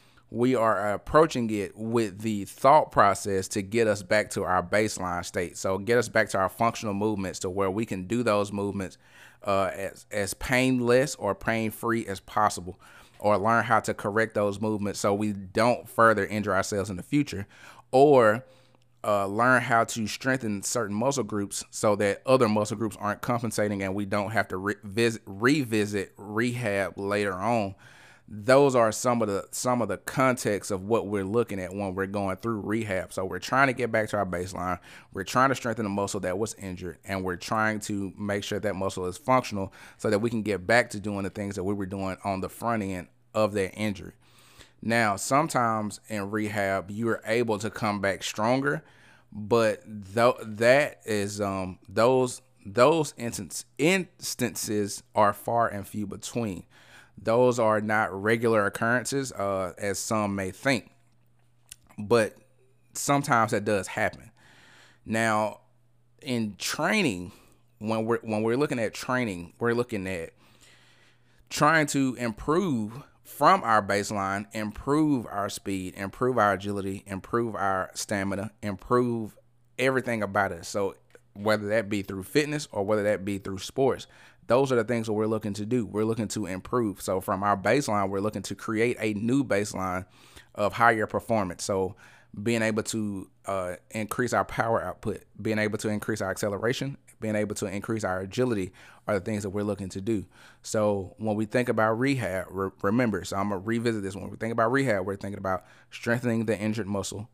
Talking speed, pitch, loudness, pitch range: 175 wpm, 105 Hz, -27 LUFS, 100-115 Hz